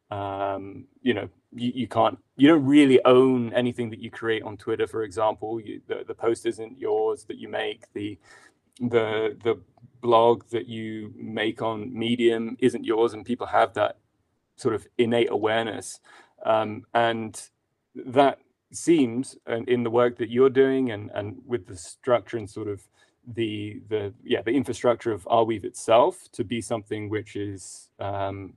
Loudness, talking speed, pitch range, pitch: -25 LUFS, 170 wpm, 110-125 Hz, 115 Hz